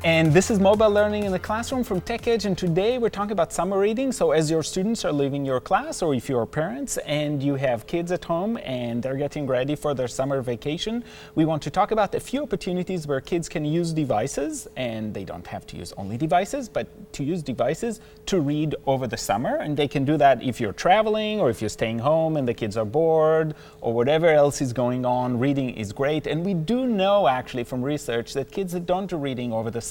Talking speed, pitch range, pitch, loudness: 230 wpm, 130-195 Hz, 155 Hz, -24 LUFS